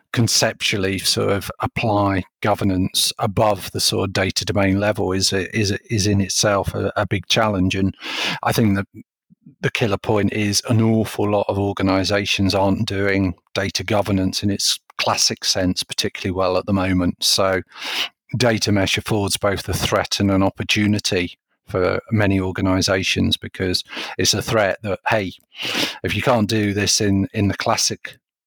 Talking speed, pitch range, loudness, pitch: 160 wpm, 95-110 Hz, -19 LUFS, 100 Hz